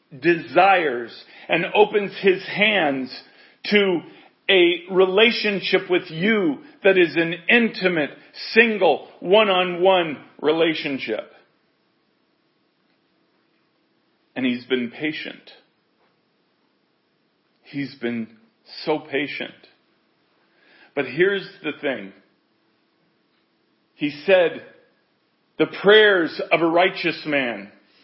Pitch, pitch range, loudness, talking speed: 175 Hz, 145-195 Hz, -20 LUFS, 80 wpm